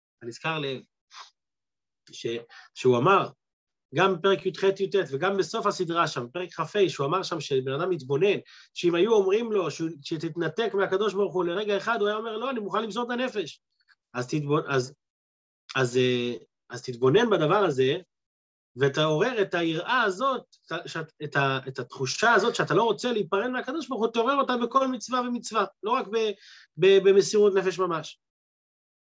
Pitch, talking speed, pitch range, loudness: 185 Hz, 155 wpm, 140-215 Hz, -26 LUFS